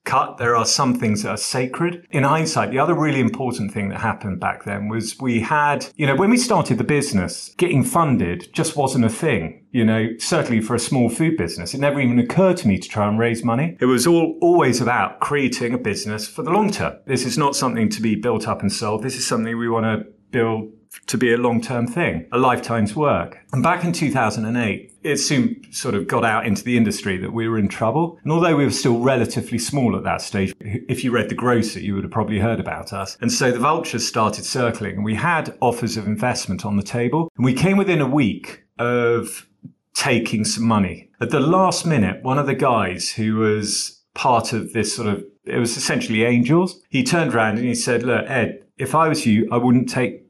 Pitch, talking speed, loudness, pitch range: 120 Hz, 225 wpm, -20 LUFS, 110-135 Hz